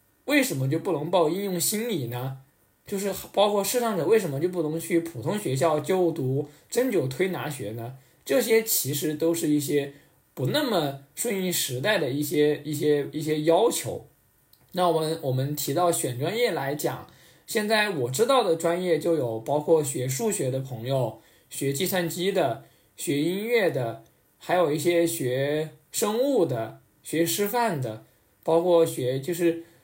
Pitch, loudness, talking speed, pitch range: 165 Hz, -25 LUFS, 235 characters per minute, 140-185 Hz